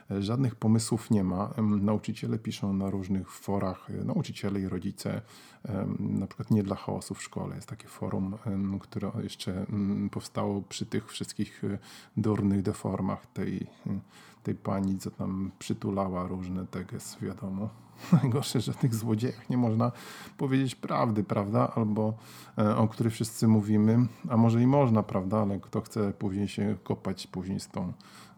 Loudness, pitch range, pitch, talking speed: -30 LUFS, 100-115 Hz, 105 Hz, 135 wpm